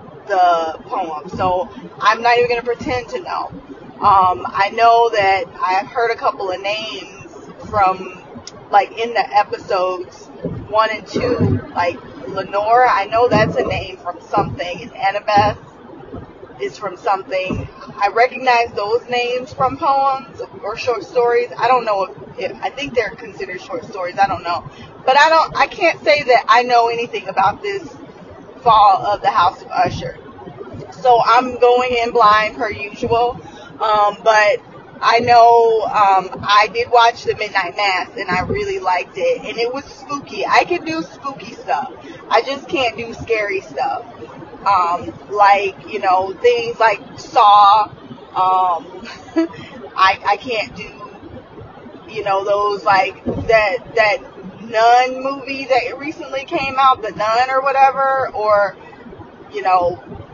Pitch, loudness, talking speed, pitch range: 225 Hz, -16 LUFS, 150 wpm, 195-260 Hz